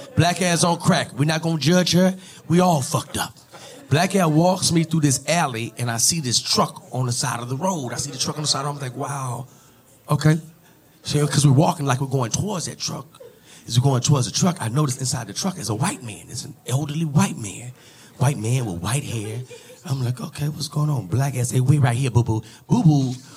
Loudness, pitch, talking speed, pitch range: -21 LUFS, 145 Hz, 245 wpm, 125-160 Hz